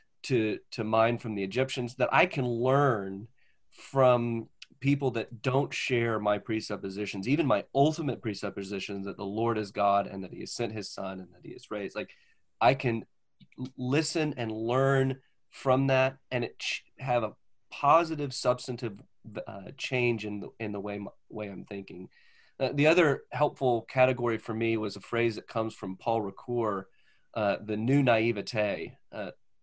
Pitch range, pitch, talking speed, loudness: 105-130 Hz, 115 Hz, 170 wpm, -29 LUFS